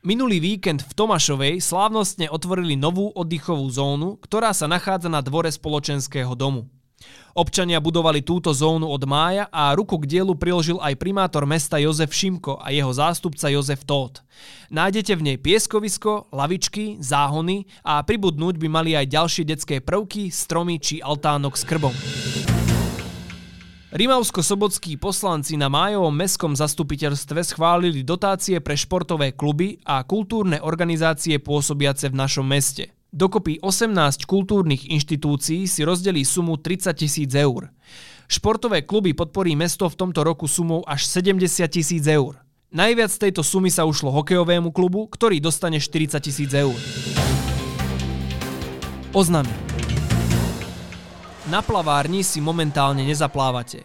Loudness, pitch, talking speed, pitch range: -21 LUFS, 160 Hz, 130 wpm, 140-185 Hz